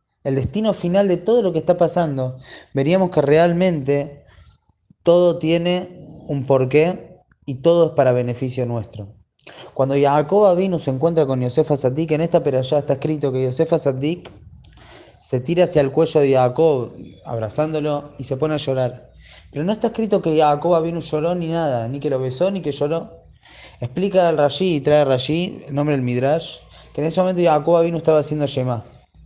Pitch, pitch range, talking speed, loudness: 150 Hz, 130-170 Hz, 185 wpm, -18 LUFS